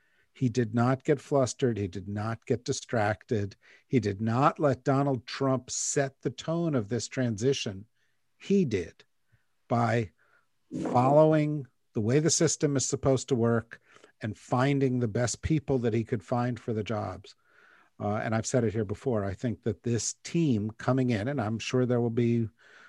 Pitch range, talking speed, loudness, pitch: 110-135 Hz, 175 wpm, -29 LUFS, 125 Hz